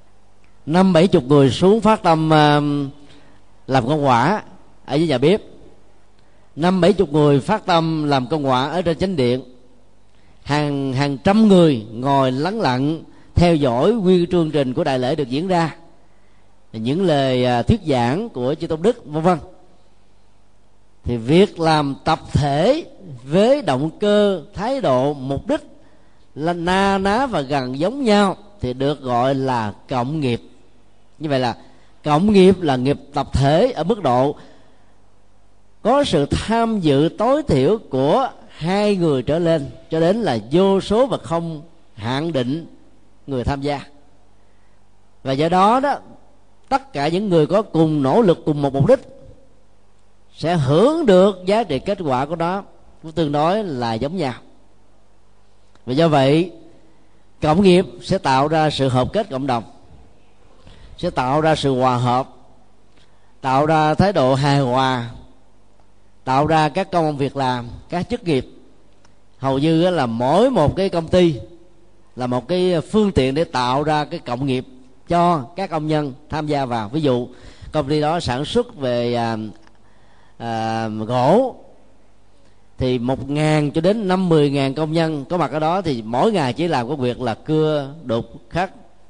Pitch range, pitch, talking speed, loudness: 120-170 Hz, 145 Hz, 165 wpm, -18 LUFS